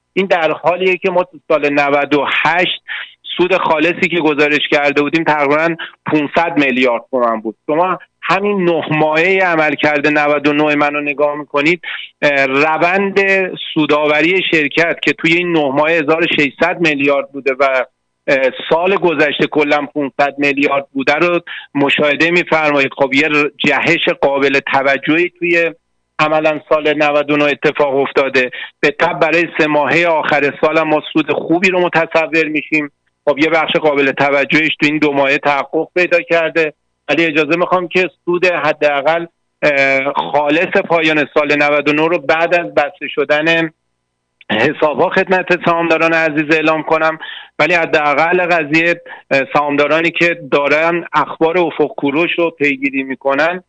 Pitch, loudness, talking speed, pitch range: 155 Hz, -13 LUFS, 135 wpm, 145-170 Hz